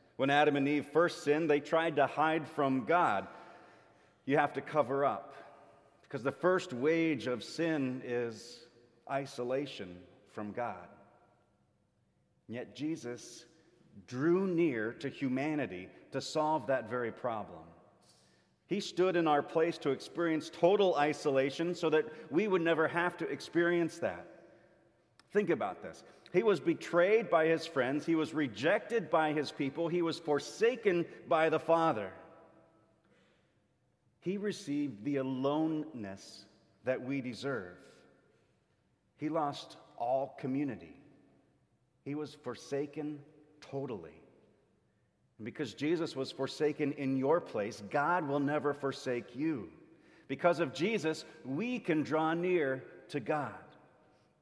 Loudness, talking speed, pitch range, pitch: -33 LUFS, 125 wpm, 130-165 Hz, 145 Hz